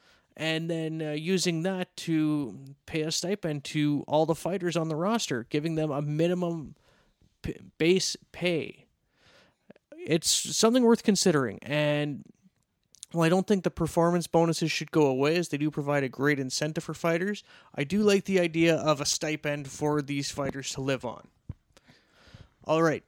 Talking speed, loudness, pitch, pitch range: 165 wpm, -27 LUFS, 160 Hz, 150-175 Hz